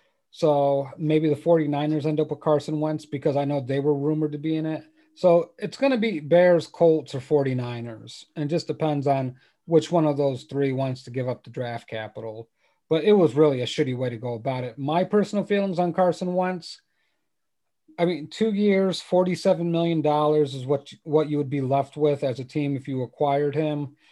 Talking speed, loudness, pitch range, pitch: 205 wpm, -24 LUFS, 140-170 Hz, 150 Hz